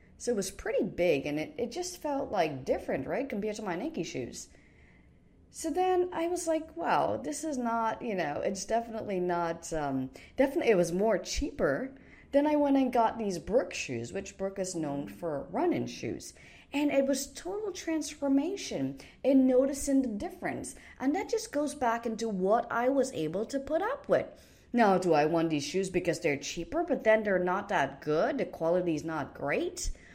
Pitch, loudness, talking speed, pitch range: 220 Hz, -31 LUFS, 190 wpm, 165-275 Hz